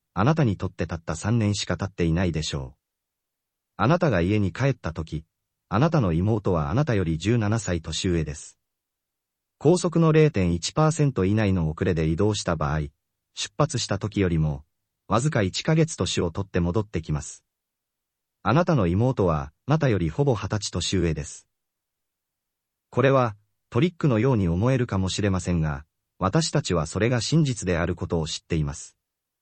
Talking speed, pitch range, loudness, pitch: 310 characters per minute, 85-115 Hz, -24 LUFS, 95 Hz